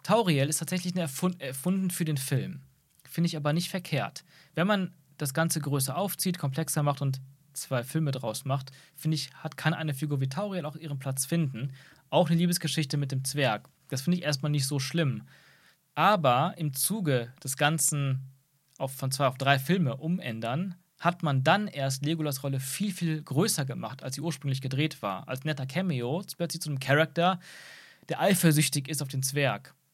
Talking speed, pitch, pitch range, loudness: 185 wpm, 150 Hz, 135-170 Hz, -29 LUFS